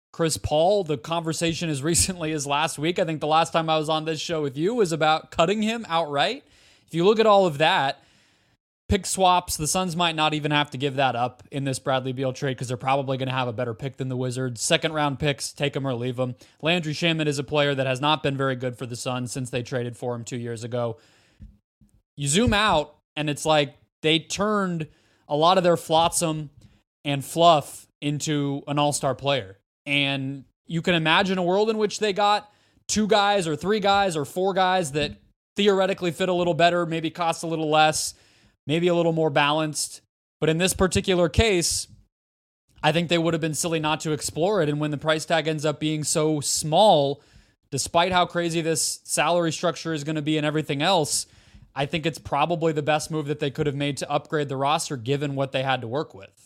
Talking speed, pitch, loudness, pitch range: 220 wpm, 150 Hz, -23 LUFS, 135-170 Hz